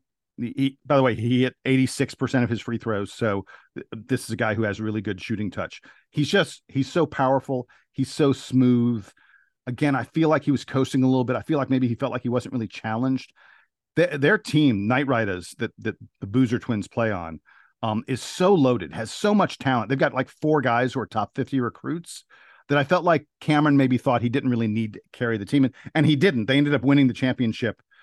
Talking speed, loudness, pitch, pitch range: 230 wpm, -23 LUFS, 130 Hz, 115-140 Hz